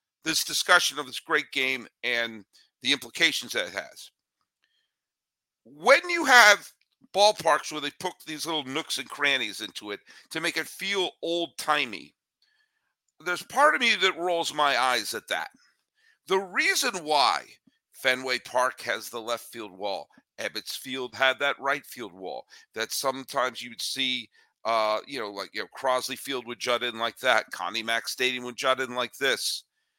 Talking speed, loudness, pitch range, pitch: 170 wpm, -26 LUFS, 125-195 Hz, 150 Hz